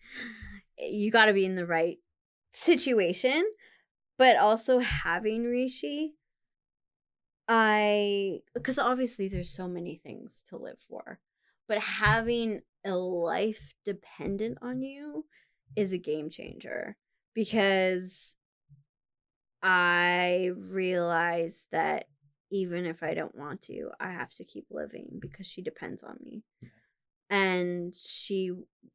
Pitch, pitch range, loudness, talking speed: 195 Hz, 175-230 Hz, -29 LUFS, 115 wpm